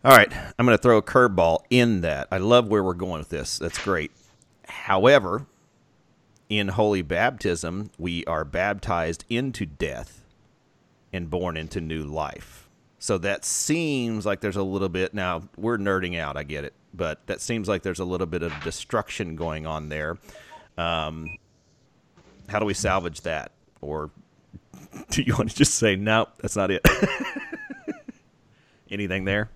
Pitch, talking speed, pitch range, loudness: 95 Hz, 165 wpm, 85-110 Hz, -24 LUFS